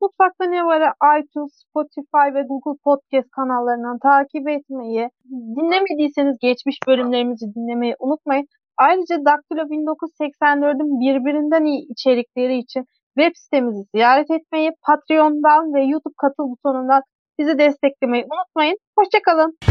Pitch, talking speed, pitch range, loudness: 290 Hz, 110 wpm, 260-310 Hz, -18 LUFS